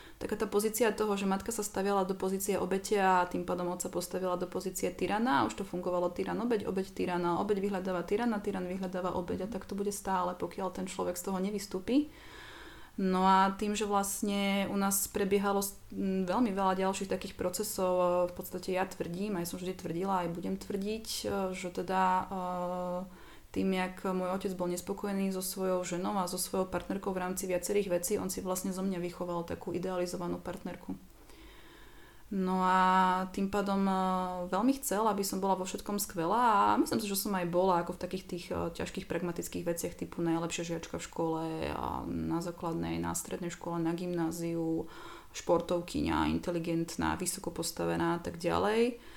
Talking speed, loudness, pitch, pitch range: 165 wpm, -33 LUFS, 185 Hz, 175-200 Hz